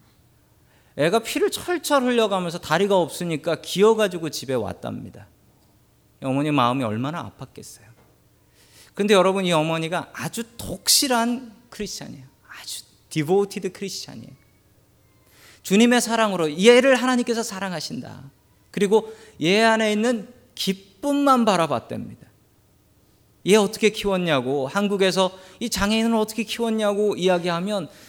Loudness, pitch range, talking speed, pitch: -21 LUFS, 140-220 Hz, 305 characters per minute, 190 Hz